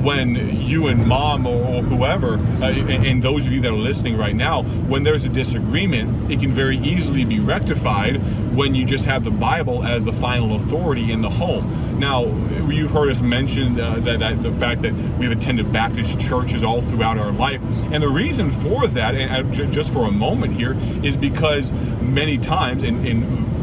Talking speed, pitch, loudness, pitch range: 195 wpm, 120 Hz, -19 LUFS, 115-130 Hz